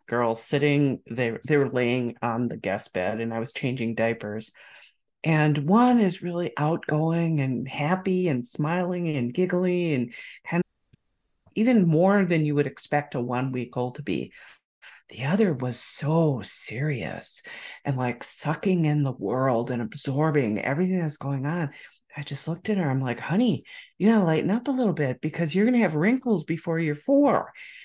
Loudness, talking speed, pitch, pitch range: -25 LUFS, 170 wpm, 150 Hz, 125-180 Hz